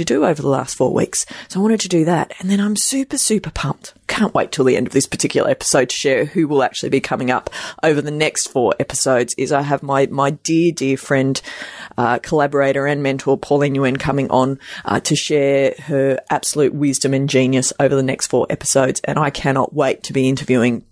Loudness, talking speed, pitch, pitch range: -17 LUFS, 220 wpm, 140 Hz, 135-155 Hz